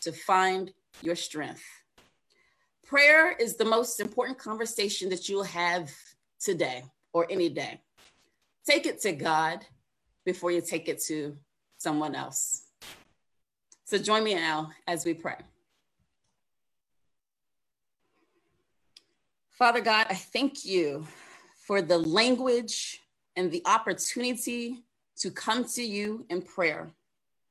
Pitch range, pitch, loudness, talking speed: 170-240 Hz, 195 Hz, -28 LUFS, 115 wpm